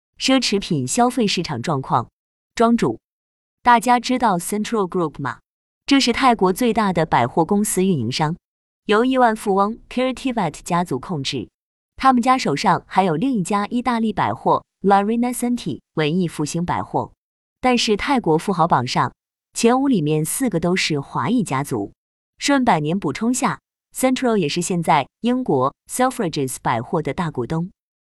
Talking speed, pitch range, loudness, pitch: 315 characters per minute, 165-245 Hz, -19 LUFS, 200 Hz